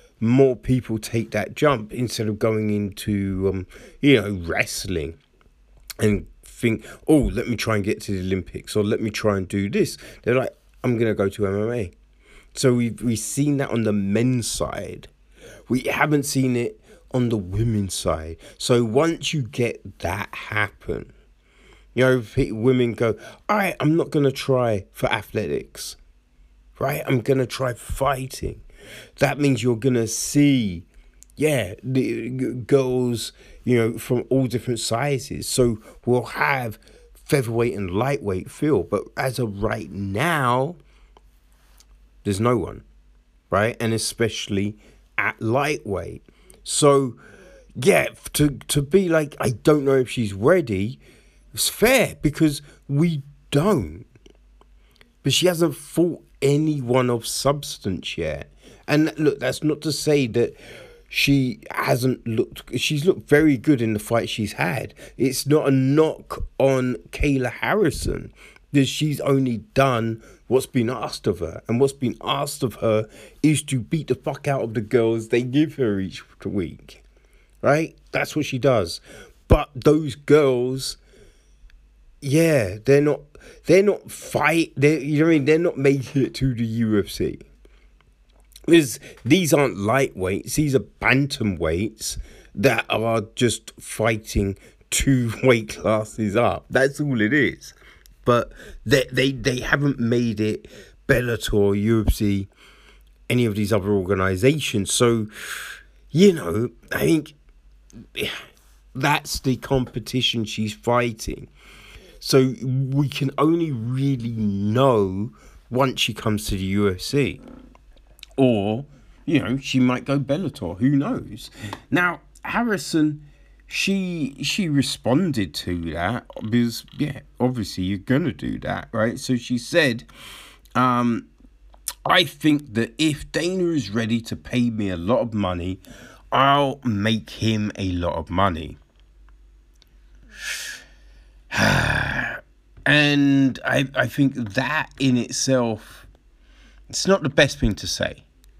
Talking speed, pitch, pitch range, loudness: 140 wpm, 120 Hz, 105-140 Hz, -22 LUFS